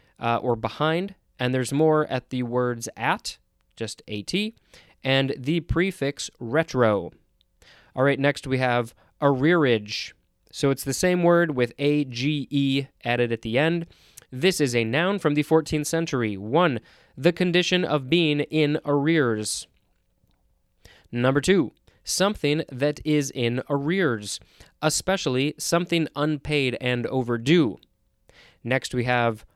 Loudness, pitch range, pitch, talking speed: -24 LUFS, 120-155 Hz, 140 Hz, 130 wpm